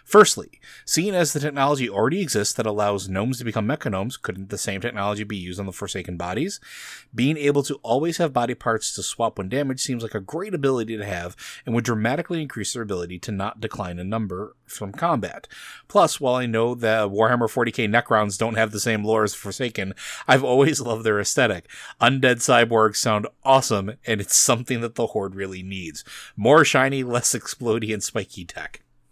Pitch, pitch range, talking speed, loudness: 115 Hz, 100-125 Hz, 190 wpm, -22 LUFS